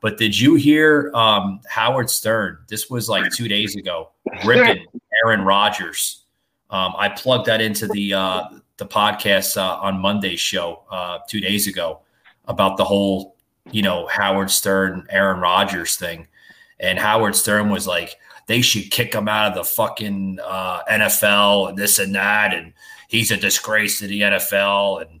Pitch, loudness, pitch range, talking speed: 105 Hz, -18 LUFS, 100-110 Hz, 165 wpm